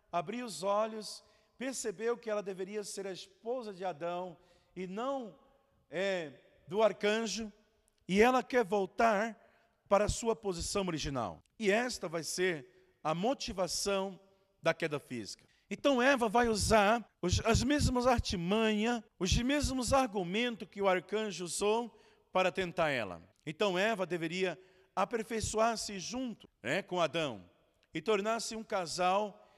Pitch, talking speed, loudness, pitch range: 200 Hz, 130 wpm, -33 LUFS, 185-225 Hz